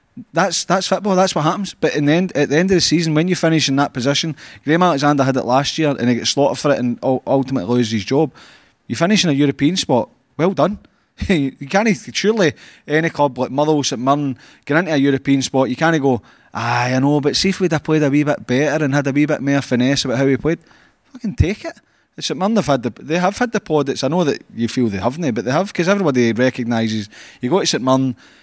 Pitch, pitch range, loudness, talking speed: 145 Hz, 130-165 Hz, -17 LUFS, 255 wpm